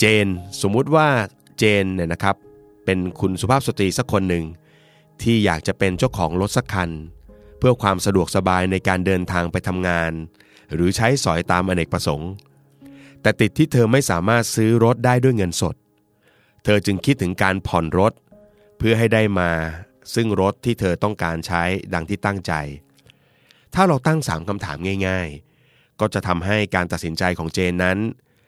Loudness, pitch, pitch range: -20 LUFS, 100 Hz, 90-115 Hz